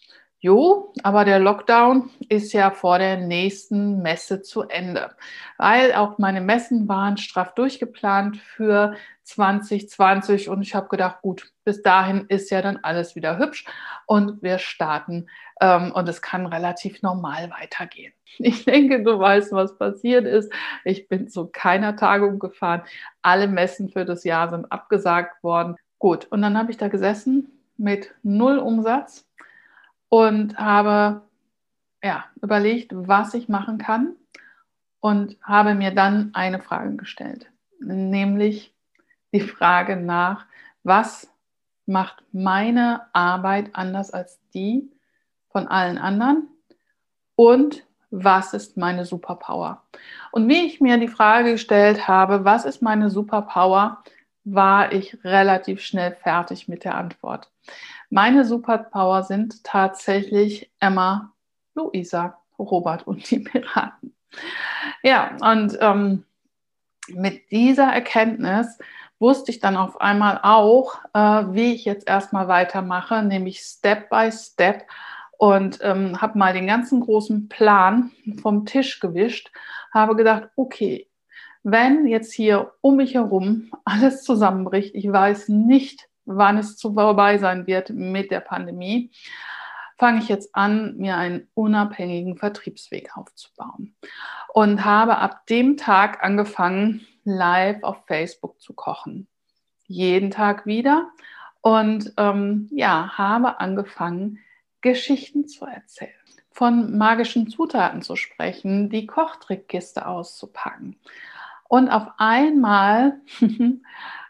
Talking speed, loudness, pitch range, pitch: 125 wpm, -20 LUFS, 190-235 Hz, 205 Hz